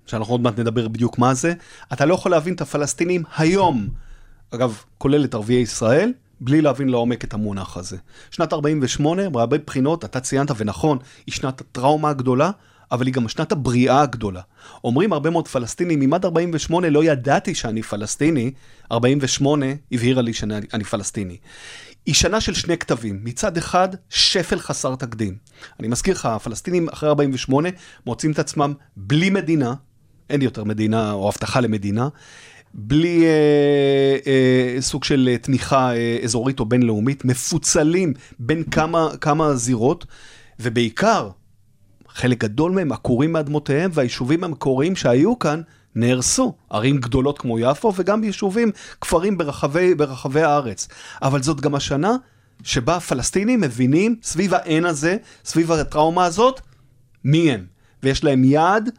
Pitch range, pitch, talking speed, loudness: 120-160 Hz, 135 Hz, 140 wpm, -19 LUFS